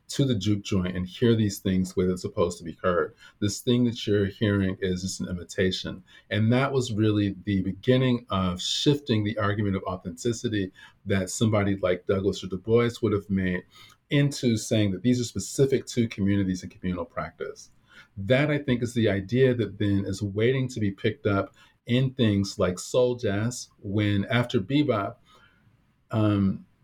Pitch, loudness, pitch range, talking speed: 105 Hz, -26 LUFS, 95-120 Hz, 175 wpm